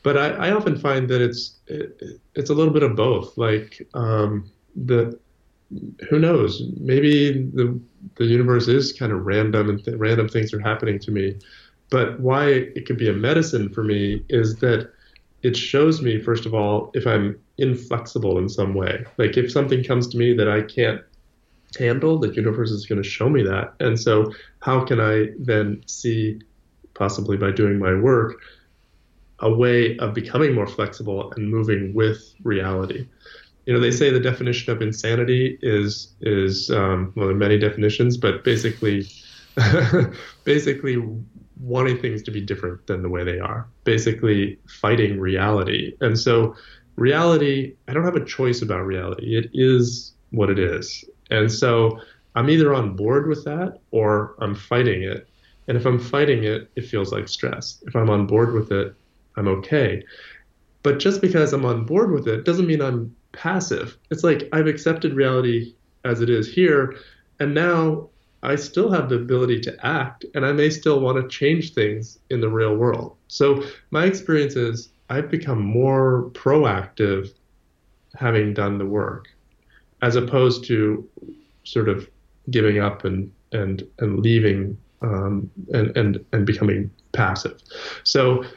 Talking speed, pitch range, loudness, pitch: 165 wpm, 105-130 Hz, -21 LUFS, 115 Hz